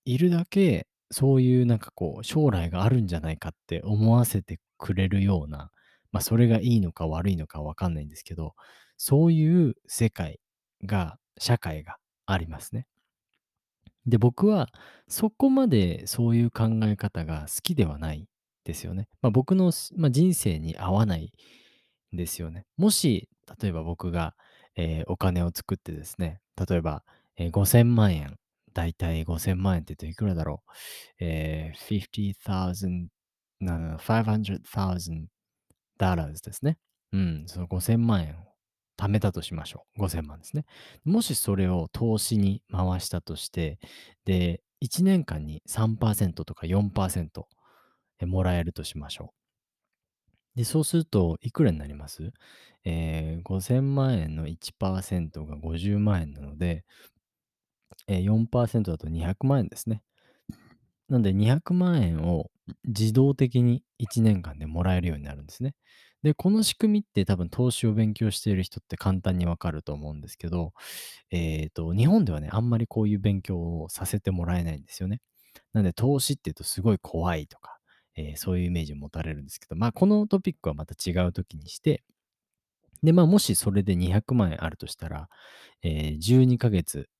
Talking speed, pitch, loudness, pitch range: 285 characters per minute, 95 Hz, -26 LUFS, 85-115 Hz